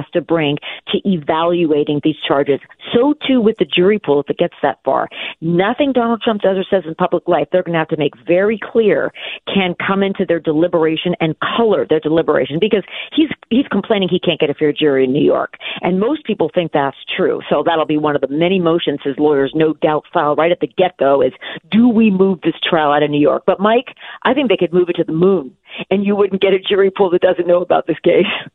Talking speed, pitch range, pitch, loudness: 240 wpm, 155-195 Hz, 175 Hz, -15 LUFS